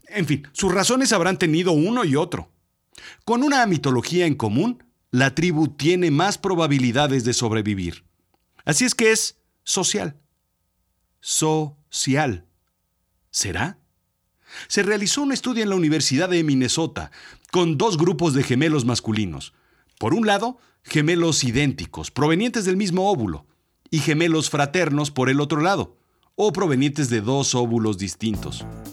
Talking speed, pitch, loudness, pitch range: 135 wpm, 150 Hz, -21 LUFS, 125-185 Hz